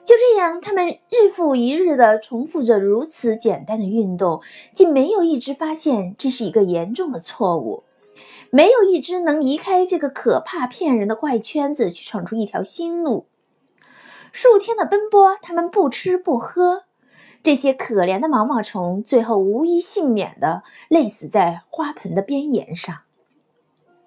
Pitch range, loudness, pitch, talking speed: 220-350 Hz, -18 LUFS, 285 Hz, 235 characters per minute